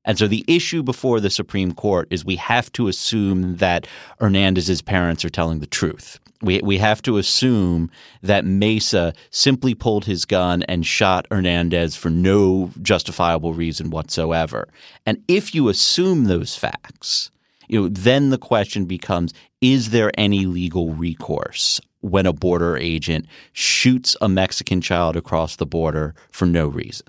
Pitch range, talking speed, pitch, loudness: 85-110 Hz, 155 wpm, 95 Hz, -19 LUFS